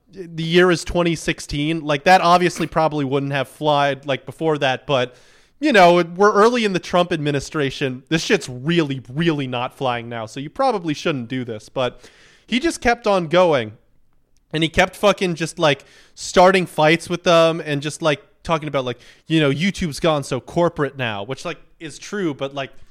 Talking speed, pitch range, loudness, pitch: 185 wpm, 135-175 Hz, -19 LUFS, 155 Hz